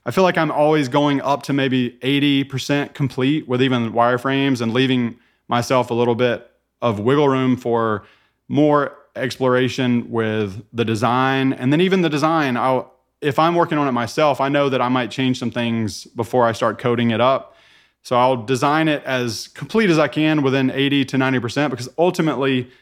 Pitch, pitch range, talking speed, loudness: 130 Hz, 120-145 Hz, 185 wpm, -19 LUFS